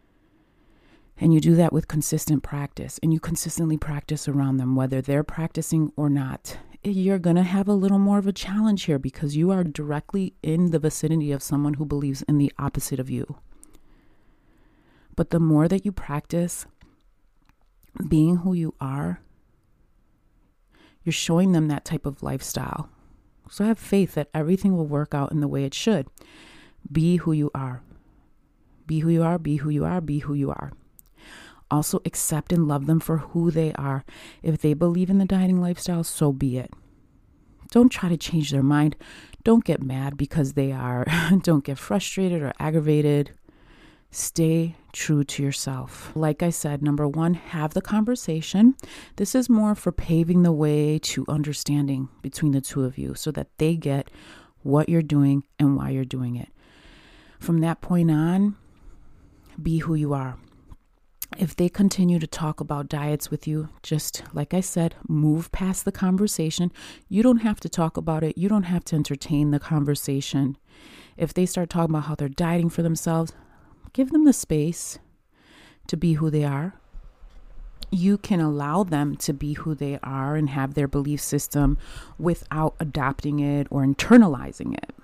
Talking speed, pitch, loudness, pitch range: 170 wpm, 155 Hz, -23 LUFS, 145-175 Hz